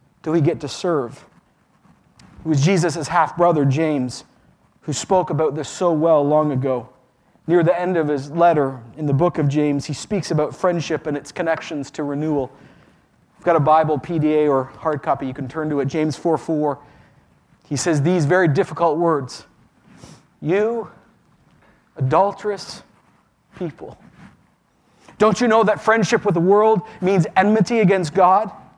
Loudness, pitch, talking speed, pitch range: -19 LUFS, 160 Hz, 160 wpm, 145-180 Hz